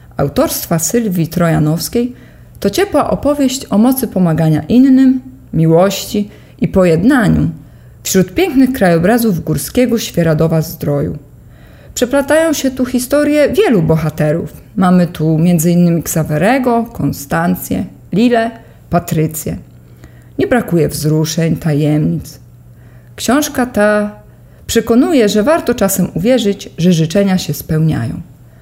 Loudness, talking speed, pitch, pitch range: -13 LUFS, 100 wpm, 185 Hz, 160-240 Hz